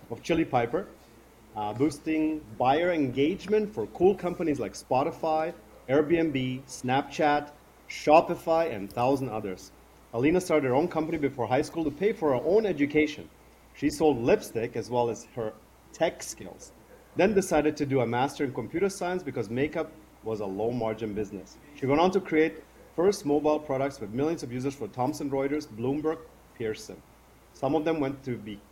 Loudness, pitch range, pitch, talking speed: -28 LUFS, 120-160 Hz, 145 Hz, 170 wpm